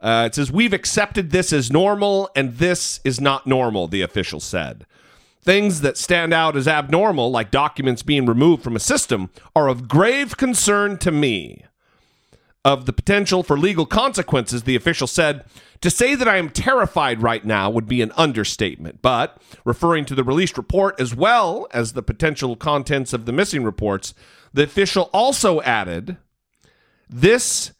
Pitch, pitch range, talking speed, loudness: 140 Hz, 120-180 Hz, 165 wpm, -18 LUFS